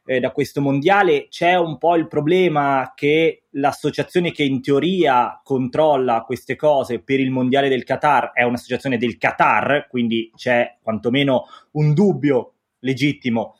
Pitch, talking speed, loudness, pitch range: 140 Hz, 135 wpm, -18 LUFS, 130-155 Hz